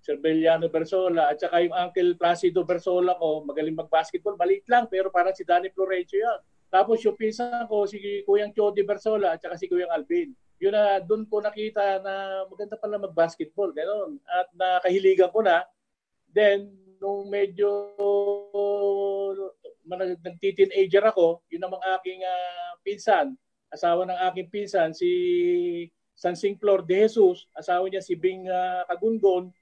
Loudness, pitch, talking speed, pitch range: -25 LUFS, 195 Hz, 155 wpm, 180-215 Hz